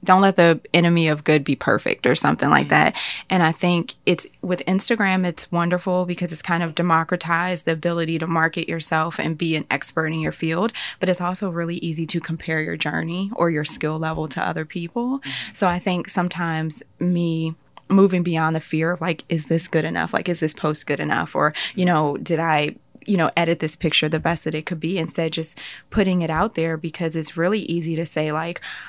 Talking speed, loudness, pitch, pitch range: 215 wpm, -21 LUFS, 165 Hz, 160-180 Hz